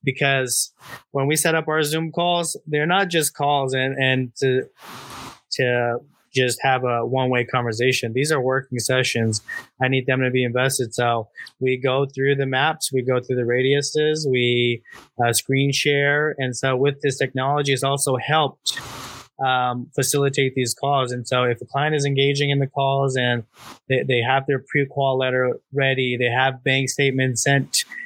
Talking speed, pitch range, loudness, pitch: 175 wpm, 125-140 Hz, -21 LUFS, 130 Hz